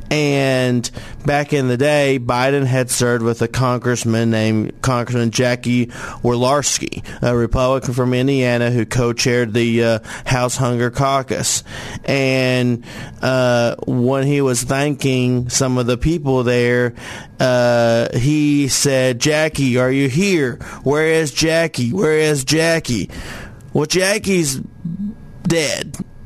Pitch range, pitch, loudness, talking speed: 120-140 Hz, 130 Hz, -17 LUFS, 120 wpm